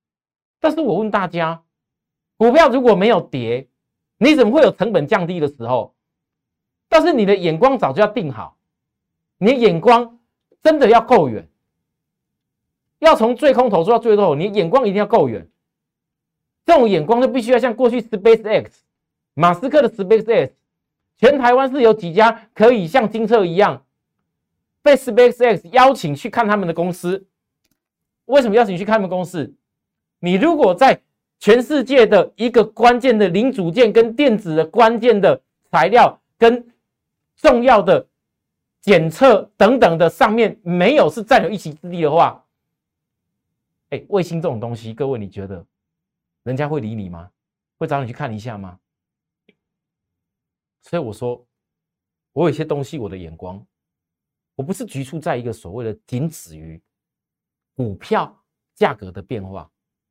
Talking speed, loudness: 235 characters per minute, -15 LUFS